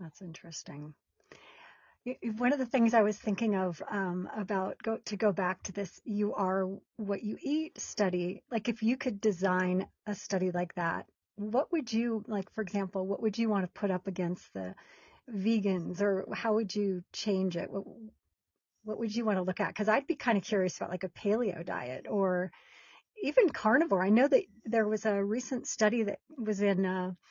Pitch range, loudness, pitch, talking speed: 190-225 Hz, -32 LUFS, 205 Hz, 200 wpm